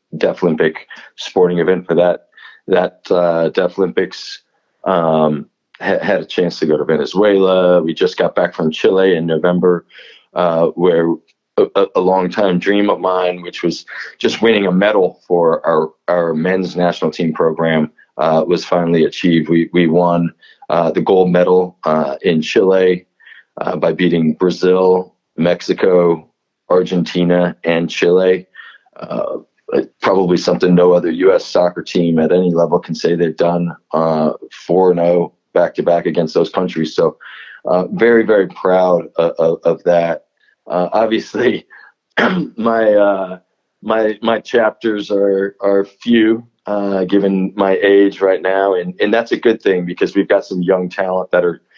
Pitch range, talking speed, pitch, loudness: 85-95 Hz, 150 wpm, 90 Hz, -15 LUFS